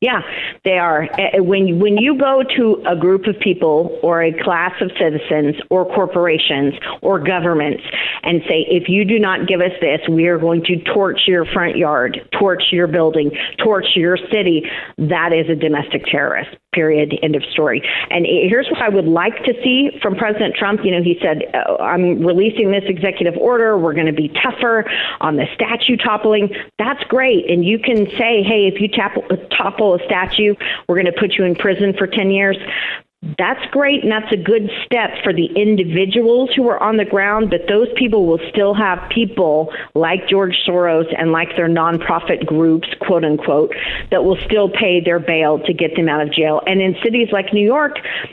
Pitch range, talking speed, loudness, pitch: 170-215 Hz, 195 wpm, -15 LUFS, 190 Hz